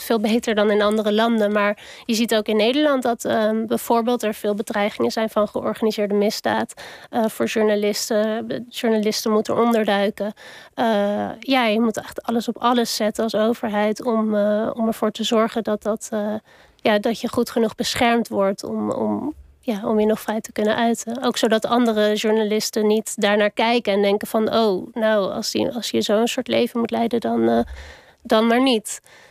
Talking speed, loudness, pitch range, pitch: 190 wpm, -20 LUFS, 210-235 Hz, 220 Hz